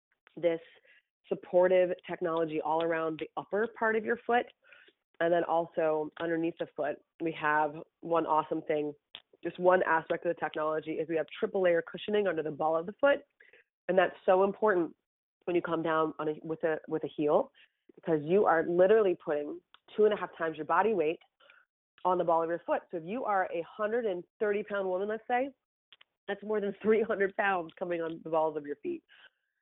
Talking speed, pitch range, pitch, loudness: 200 wpm, 160-210 Hz, 175 Hz, -31 LUFS